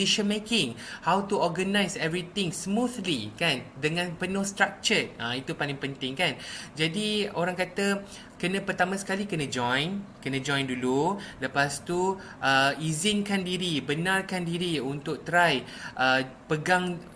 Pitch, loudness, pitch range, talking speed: 180 Hz, -27 LUFS, 140-195 Hz, 135 wpm